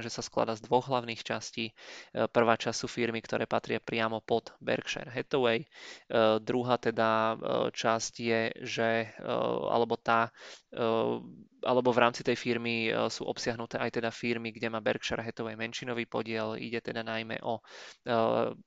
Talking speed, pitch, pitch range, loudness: 160 wpm, 115 Hz, 110-120 Hz, -31 LUFS